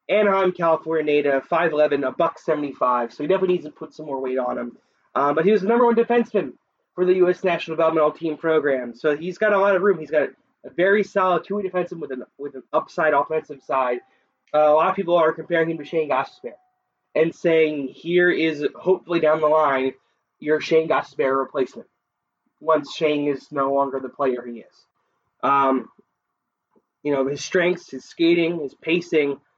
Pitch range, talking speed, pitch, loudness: 140-180 Hz, 195 wpm, 160 Hz, -21 LUFS